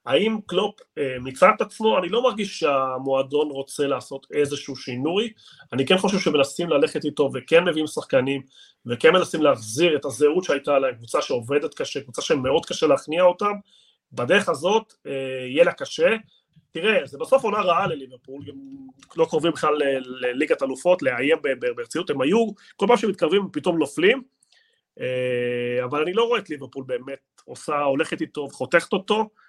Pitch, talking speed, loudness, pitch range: 165 Hz, 155 wpm, -22 LUFS, 135-220 Hz